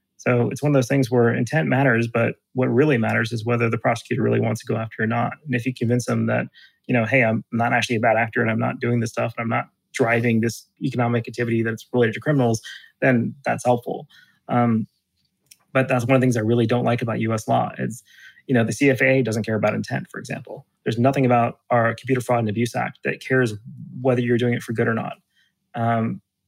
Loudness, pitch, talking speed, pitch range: -21 LUFS, 120 Hz, 235 wpm, 115-125 Hz